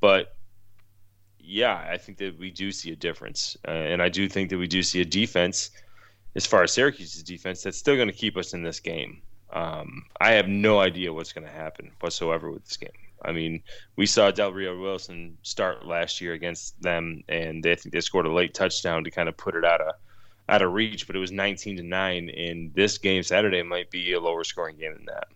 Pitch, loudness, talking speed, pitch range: 95 Hz, -25 LUFS, 225 wpm, 85-100 Hz